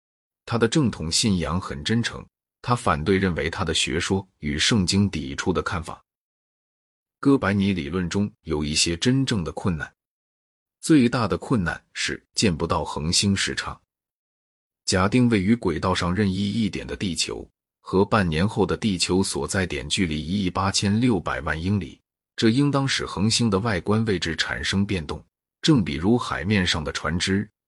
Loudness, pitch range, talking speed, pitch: -23 LUFS, 80-105 Hz, 245 characters per minute, 95 Hz